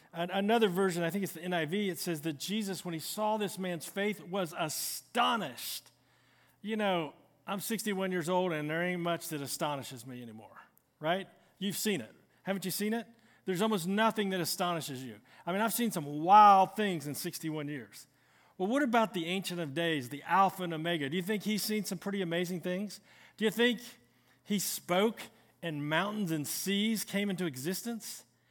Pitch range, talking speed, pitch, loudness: 165-205 Hz, 185 wpm, 185 Hz, -32 LUFS